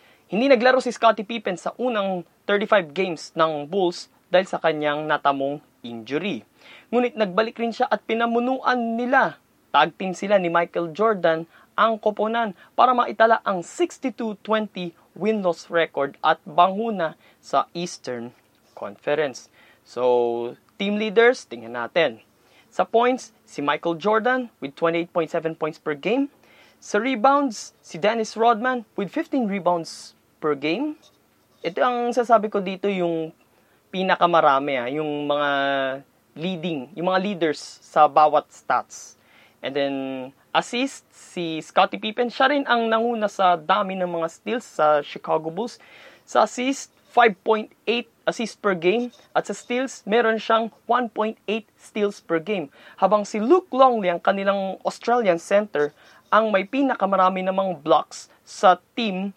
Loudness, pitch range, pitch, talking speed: -22 LUFS, 165-230 Hz, 195 Hz, 130 wpm